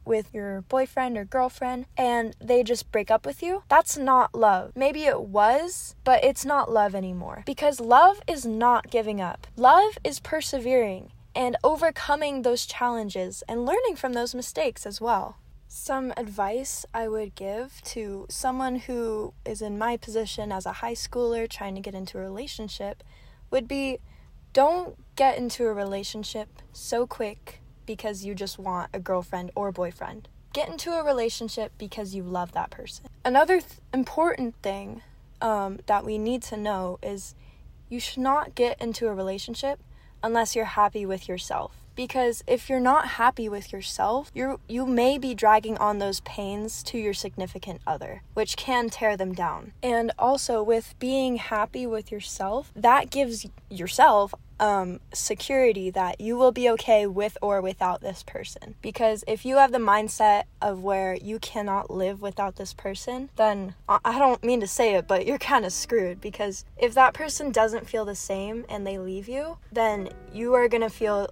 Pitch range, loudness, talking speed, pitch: 205-255 Hz, -25 LUFS, 170 wpm, 225 Hz